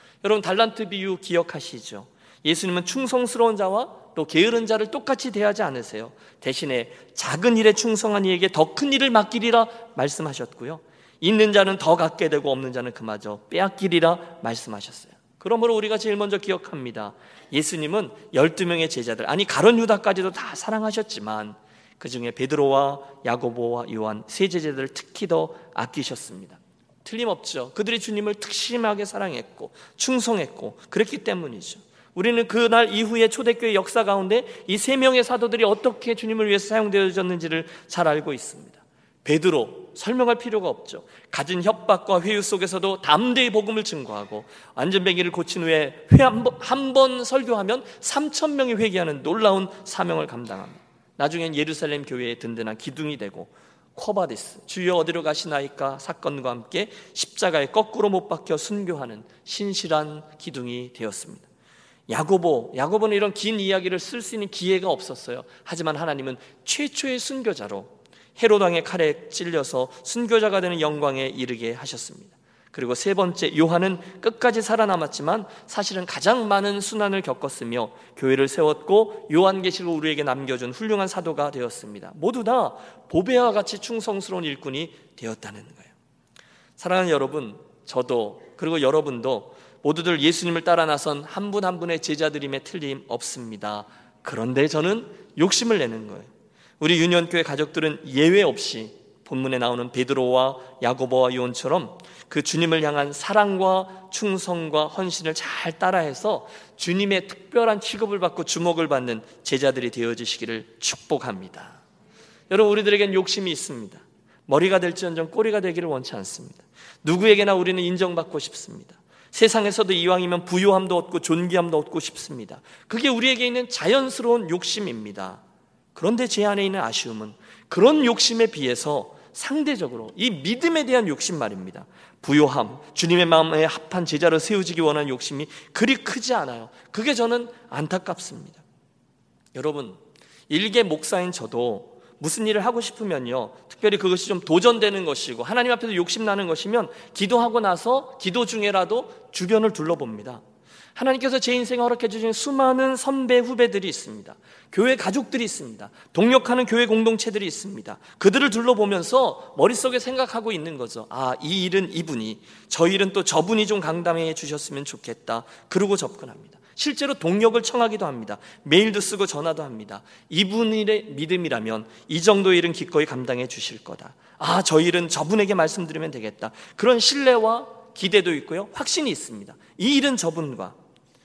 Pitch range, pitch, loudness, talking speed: 150-225 Hz, 185 Hz, -22 LUFS, 360 characters per minute